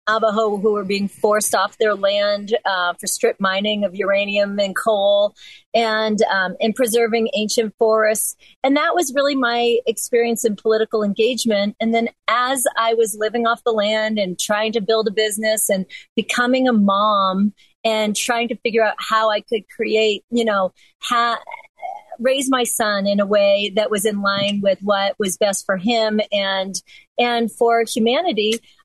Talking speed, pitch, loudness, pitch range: 170 wpm, 220 Hz, -18 LUFS, 205-235 Hz